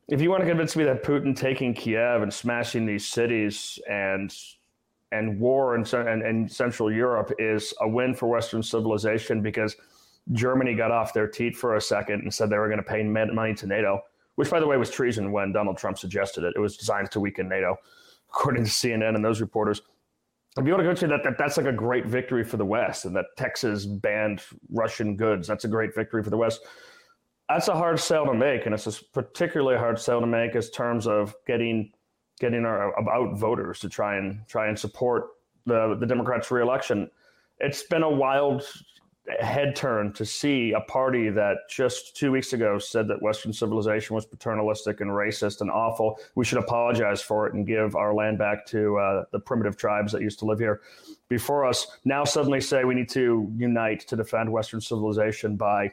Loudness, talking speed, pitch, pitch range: -26 LUFS, 205 wpm, 110 Hz, 105-125 Hz